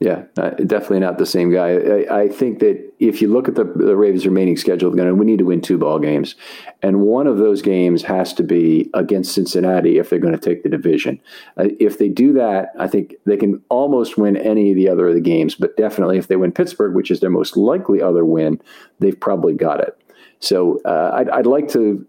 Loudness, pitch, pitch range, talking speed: -16 LUFS, 95 Hz, 90-105 Hz, 235 wpm